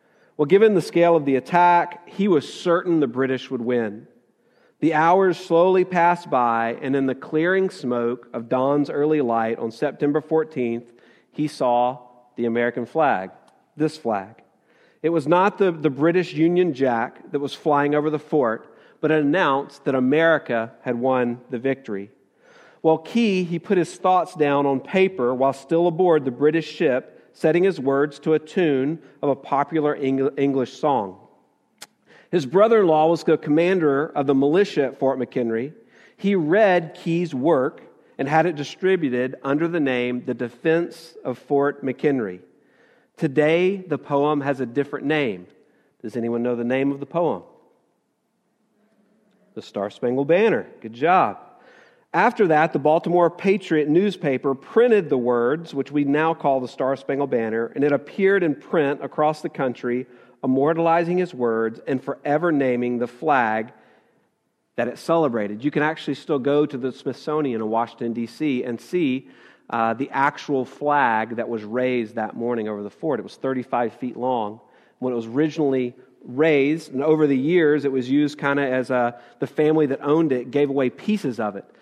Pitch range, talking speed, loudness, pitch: 125-165 Hz, 170 wpm, -21 LUFS, 145 Hz